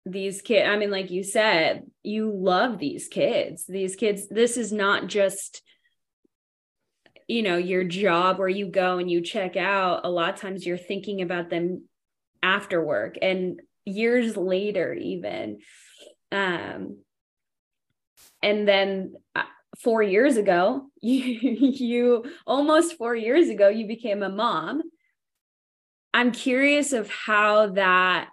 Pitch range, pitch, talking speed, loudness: 190-240 Hz, 205 Hz, 135 wpm, -24 LUFS